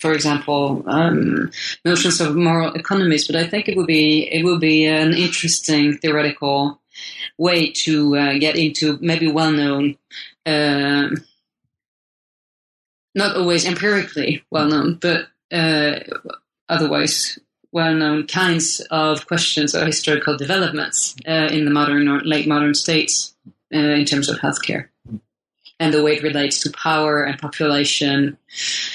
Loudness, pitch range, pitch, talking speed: -18 LUFS, 145-165 Hz, 155 Hz, 135 wpm